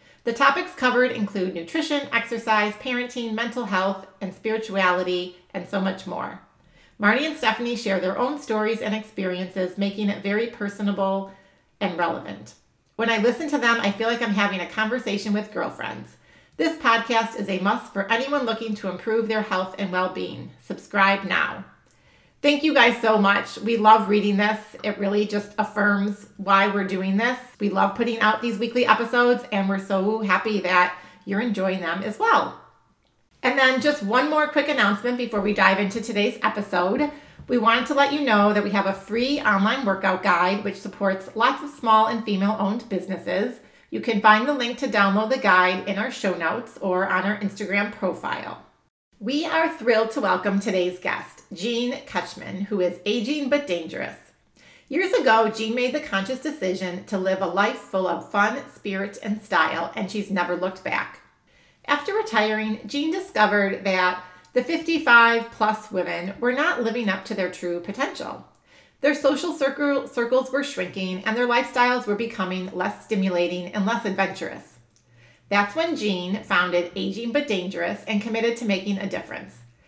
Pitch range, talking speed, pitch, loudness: 190-240 Hz, 175 wpm, 210 Hz, -23 LUFS